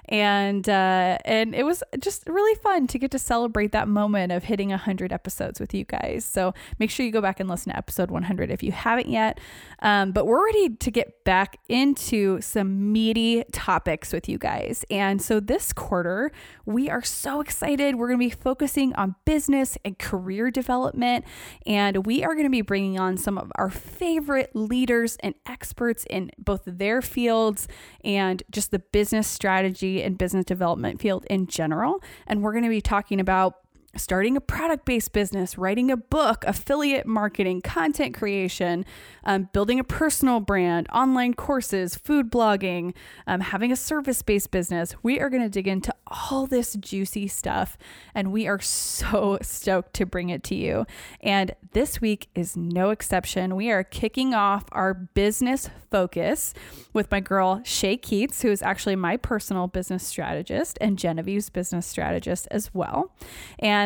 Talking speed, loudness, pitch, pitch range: 170 wpm, -25 LUFS, 210 Hz, 190-250 Hz